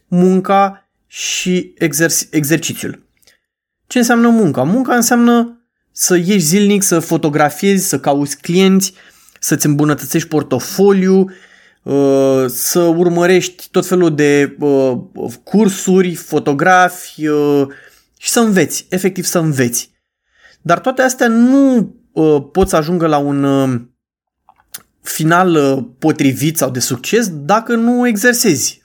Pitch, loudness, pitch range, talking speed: 175 Hz, -13 LUFS, 150-200 Hz, 100 wpm